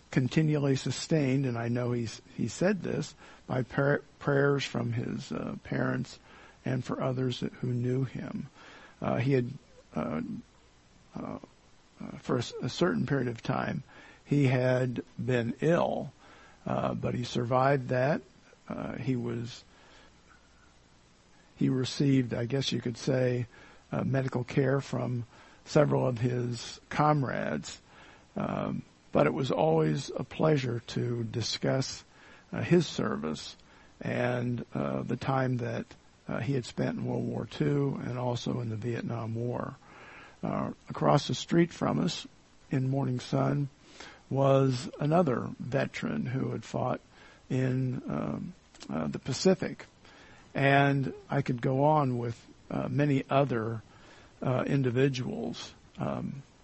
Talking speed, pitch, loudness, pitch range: 130 wpm, 130 Hz, -31 LUFS, 120-140 Hz